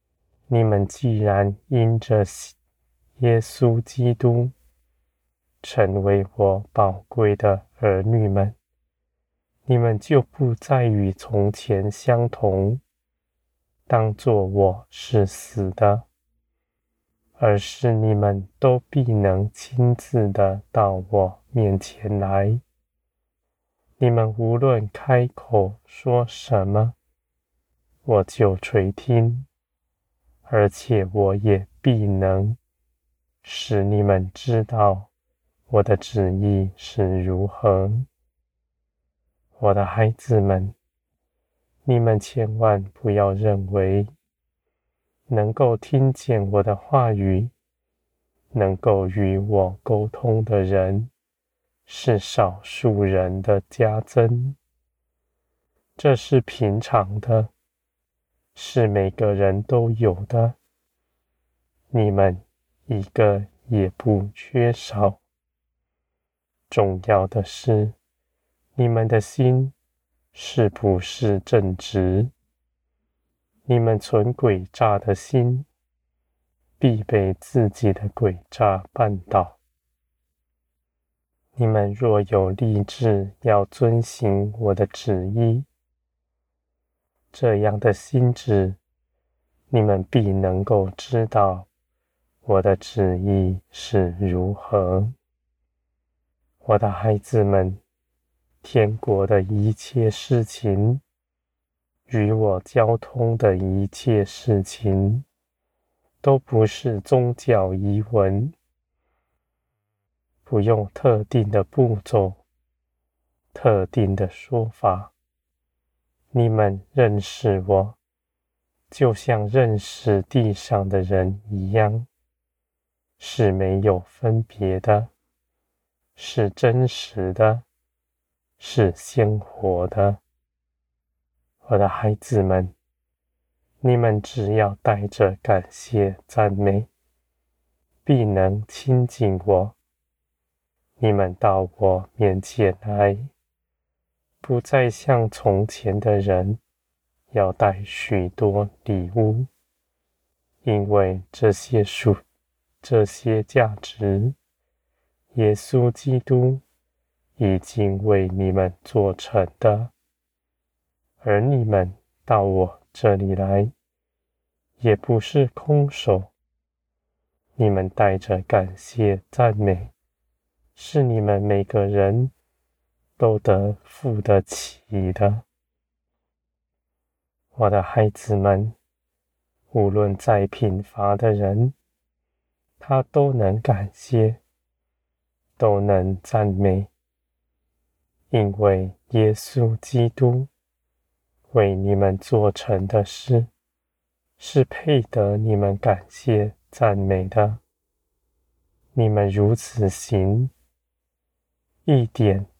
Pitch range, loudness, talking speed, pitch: 70-110 Hz, -21 LUFS, 120 characters per minute, 100 Hz